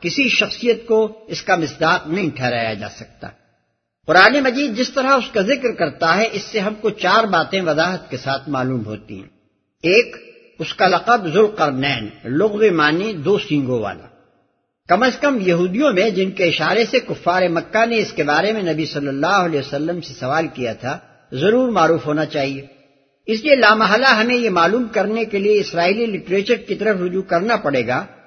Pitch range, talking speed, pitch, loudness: 145-220 Hz, 185 wpm, 180 Hz, -17 LUFS